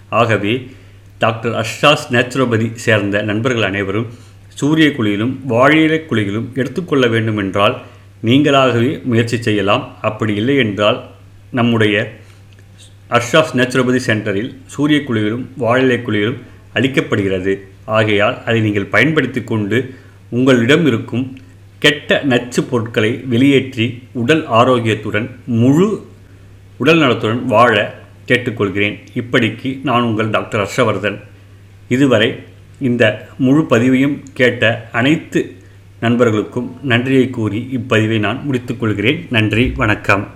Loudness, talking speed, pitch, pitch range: -15 LUFS, 95 wpm, 115 Hz, 105-130 Hz